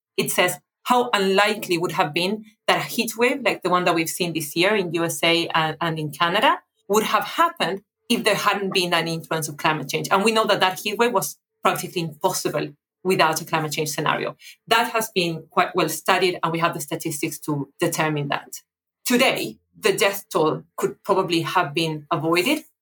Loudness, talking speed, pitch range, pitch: -22 LUFS, 190 wpm, 165-205 Hz, 180 Hz